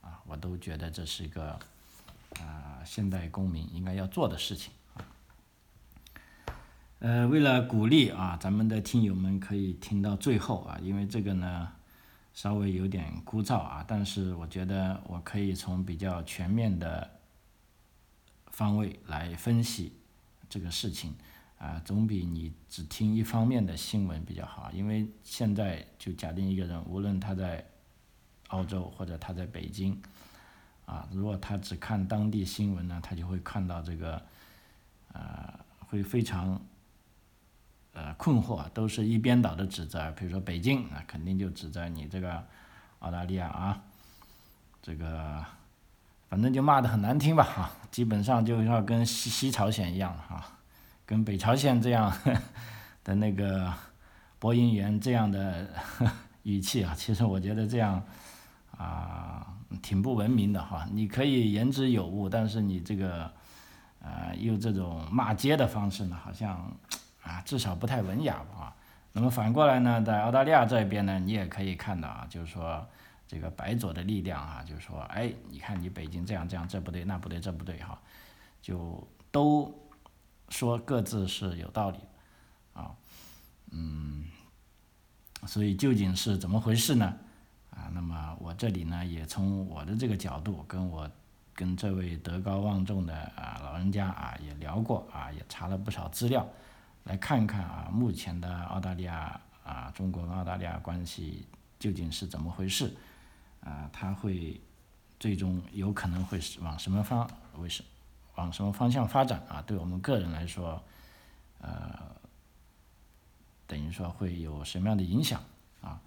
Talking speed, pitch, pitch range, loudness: 230 characters per minute, 95 Hz, 85-105 Hz, -32 LUFS